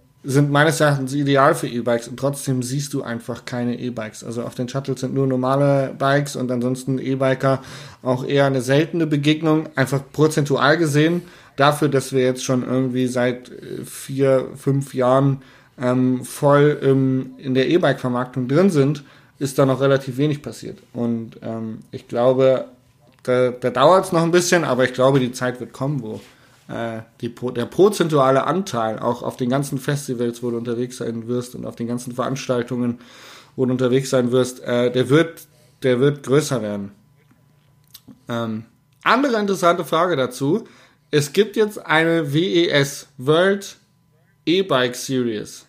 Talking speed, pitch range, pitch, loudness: 160 wpm, 125-145 Hz, 135 Hz, -20 LUFS